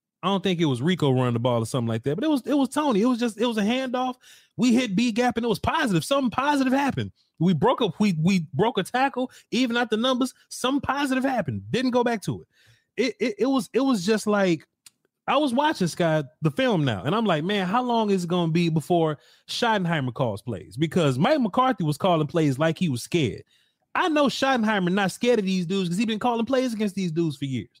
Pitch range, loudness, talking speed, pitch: 165-250 Hz, -24 LUFS, 250 wpm, 205 Hz